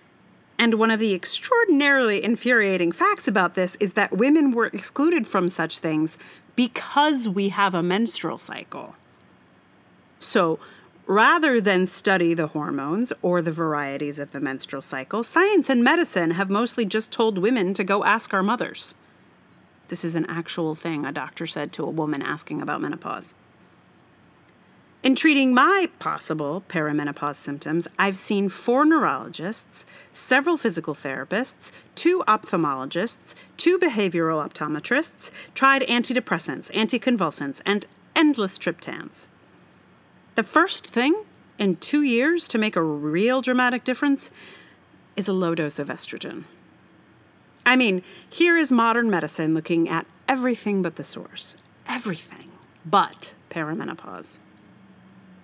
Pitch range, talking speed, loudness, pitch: 165-255 Hz, 130 wpm, -22 LUFS, 205 Hz